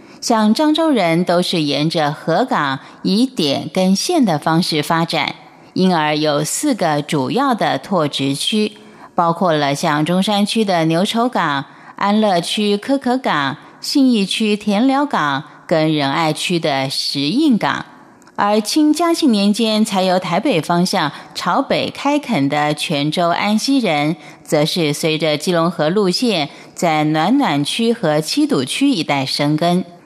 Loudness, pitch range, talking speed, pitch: -16 LUFS, 150-225 Hz, 210 characters per minute, 175 Hz